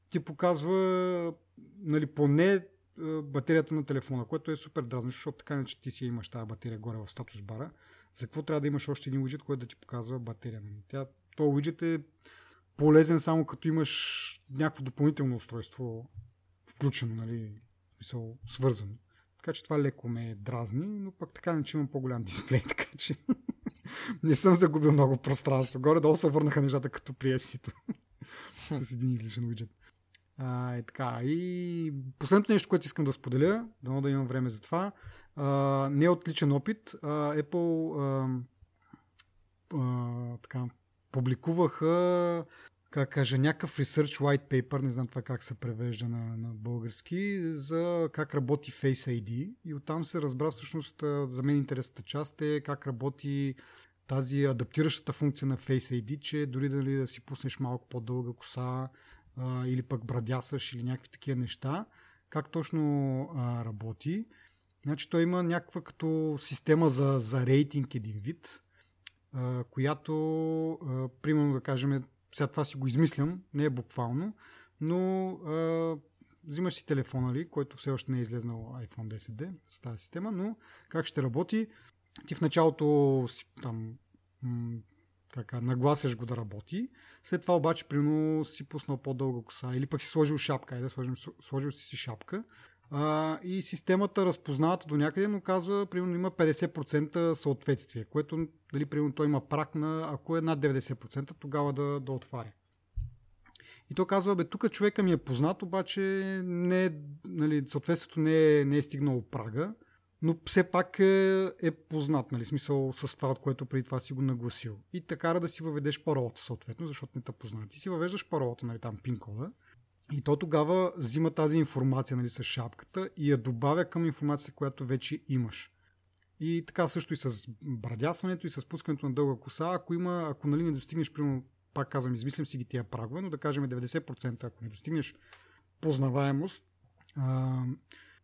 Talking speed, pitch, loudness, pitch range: 160 wpm, 140 Hz, -32 LUFS, 125-160 Hz